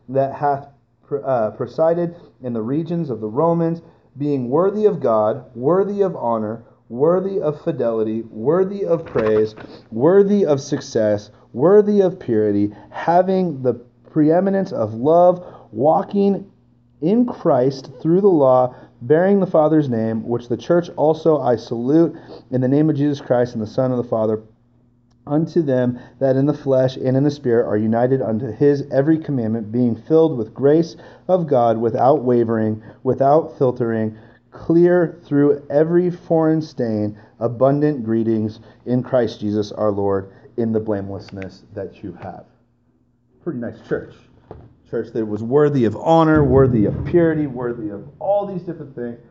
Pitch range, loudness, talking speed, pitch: 115-160 Hz, -18 LUFS, 150 wpm, 130 Hz